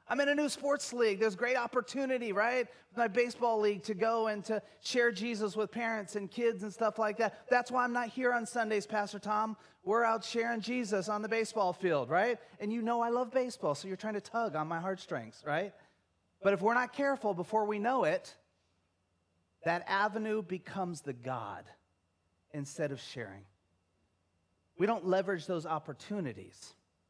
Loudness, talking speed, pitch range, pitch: -34 LUFS, 180 wpm, 155-235 Hz, 210 Hz